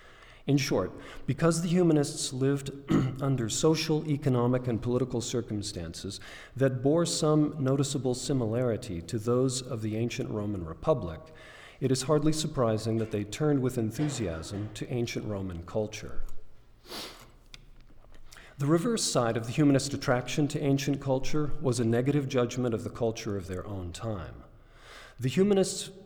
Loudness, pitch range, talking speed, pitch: -29 LUFS, 110-145 Hz, 140 wpm, 125 Hz